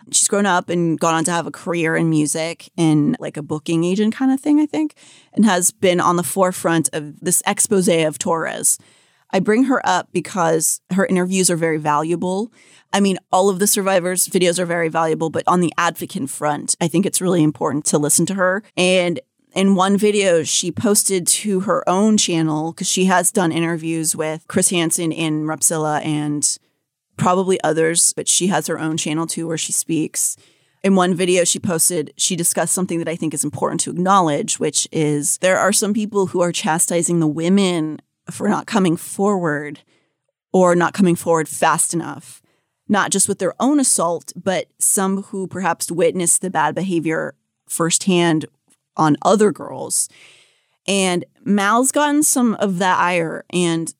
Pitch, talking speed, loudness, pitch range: 175 Hz, 180 wpm, -17 LUFS, 160-190 Hz